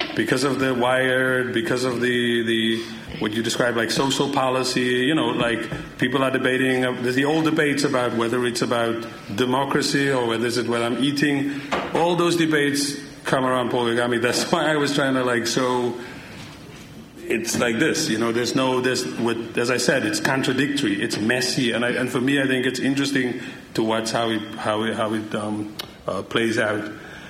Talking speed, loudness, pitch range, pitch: 195 wpm, -22 LUFS, 115-135 Hz, 125 Hz